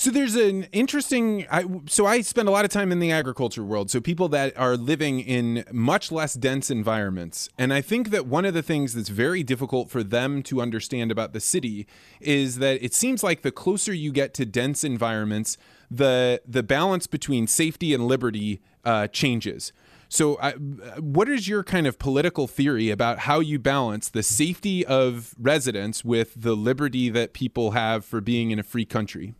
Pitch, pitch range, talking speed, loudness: 130 Hz, 115-160 Hz, 190 wpm, -24 LUFS